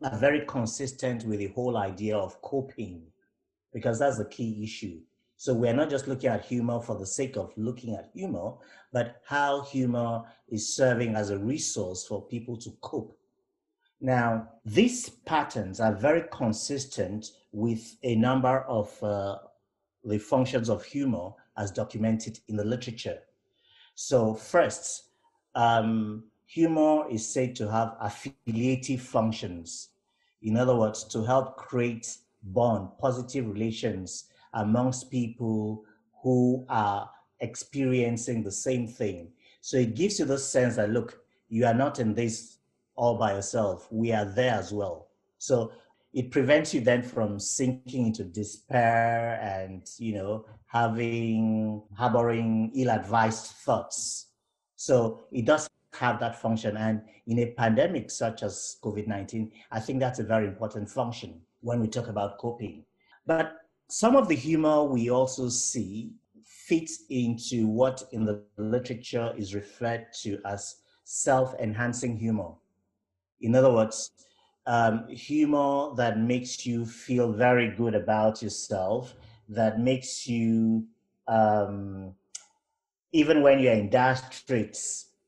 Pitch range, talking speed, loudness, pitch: 110-130 Hz, 135 wpm, -28 LUFS, 115 Hz